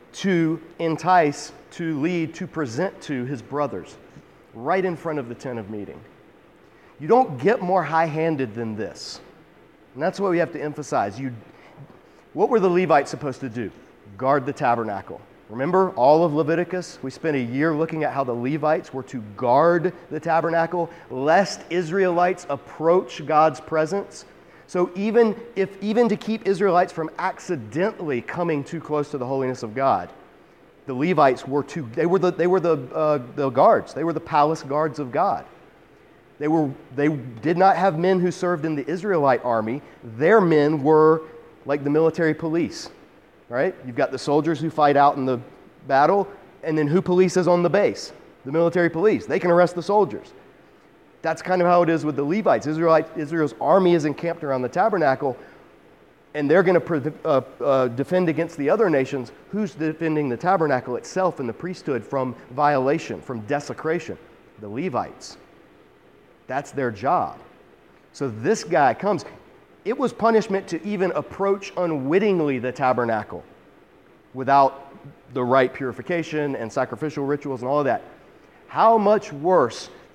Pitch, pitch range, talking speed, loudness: 155 Hz, 140-175 Hz, 165 wpm, -22 LUFS